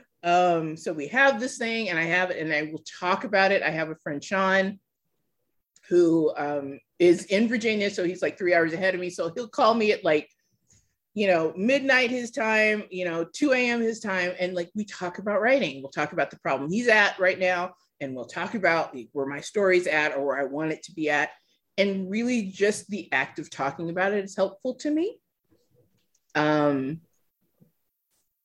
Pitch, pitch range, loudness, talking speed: 180 Hz, 155-210 Hz, -25 LUFS, 205 wpm